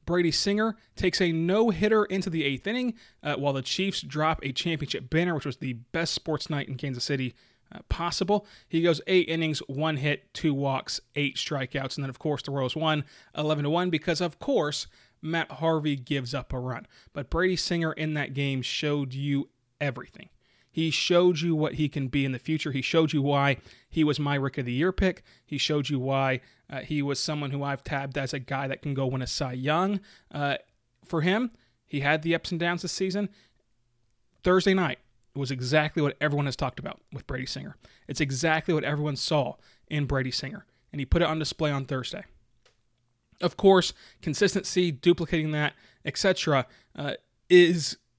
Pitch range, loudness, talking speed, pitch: 135-170 Hz, -27 LUFS, 195 wpm, 150 Hz